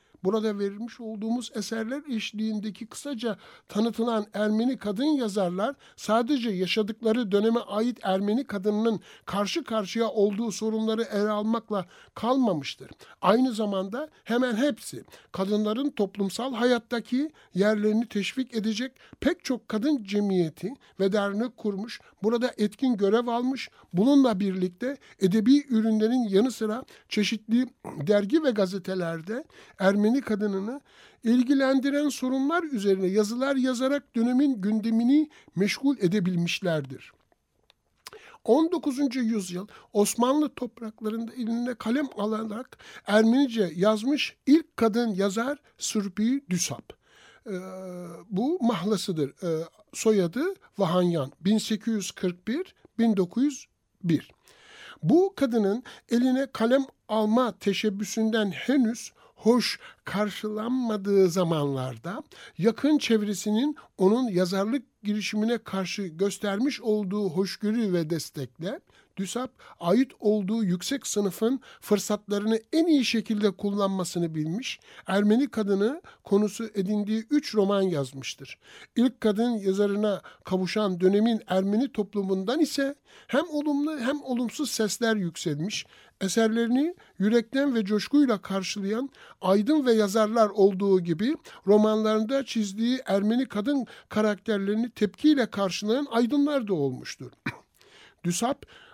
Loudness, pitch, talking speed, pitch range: -26 LUFS, 220 Hz, 95 wpm, 200-250 Hz